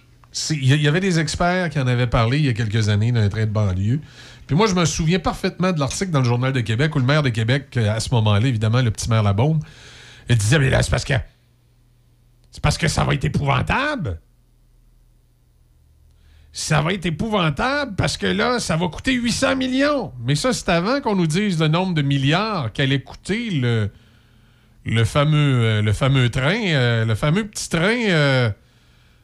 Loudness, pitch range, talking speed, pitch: -20 LUFS, 115-170 Hz, 195 wpm, 130 Hz